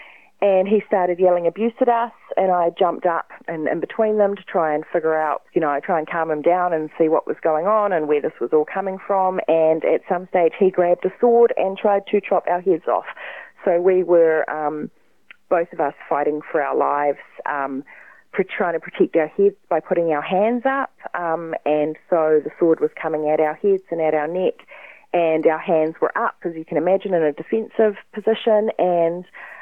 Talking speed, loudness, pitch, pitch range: 215 wpm, -20 LUFS, 175 Hz, 160-200 Hz